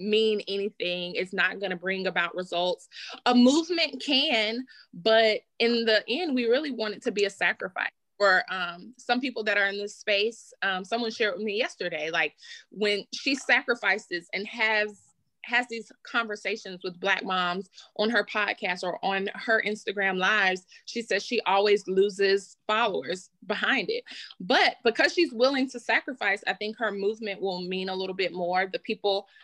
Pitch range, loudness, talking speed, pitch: 190-235 Hz, -26 LUFS, 175 wpm, 210 Hz